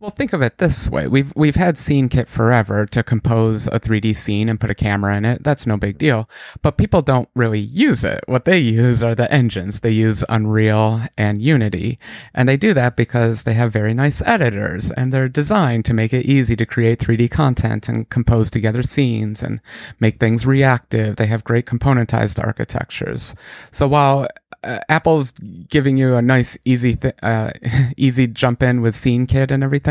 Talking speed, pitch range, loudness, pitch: 190 wpm, 110-135 Hz, -17 LUFS, 120 Hz